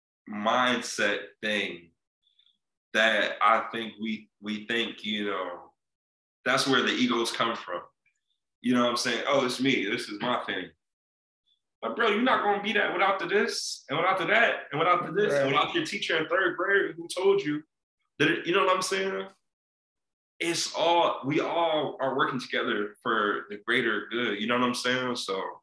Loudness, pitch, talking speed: -27 LUFS, 125 Hz, 190 wpm